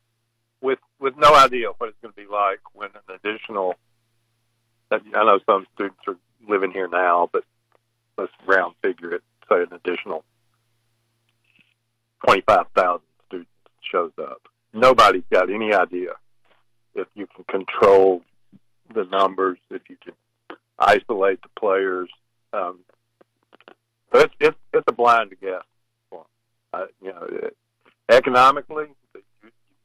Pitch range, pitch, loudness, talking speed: 100-115 Hz, 115 Hz, -20 LUFS, 125 wpm